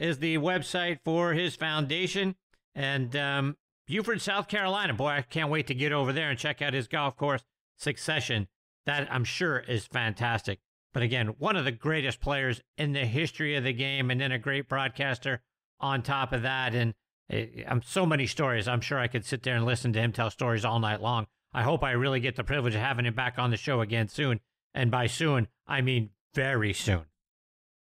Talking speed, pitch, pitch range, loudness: 210 wpm, 135 Hz, 120-145 Hz, -29 LUFS